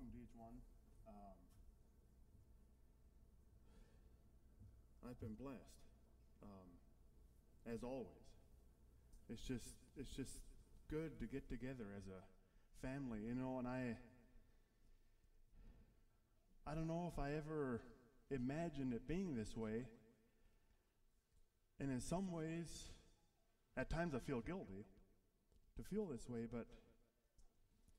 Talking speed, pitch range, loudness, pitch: 105 wpm, 95-130 Hz, -50 LUFS, 115 Hz